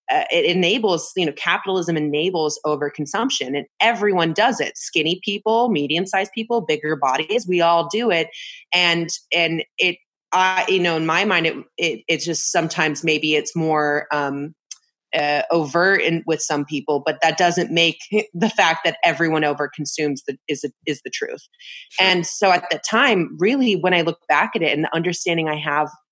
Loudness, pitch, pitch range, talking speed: -19 LUFS, 170 Hz, 155-190 Hz, 180 wpm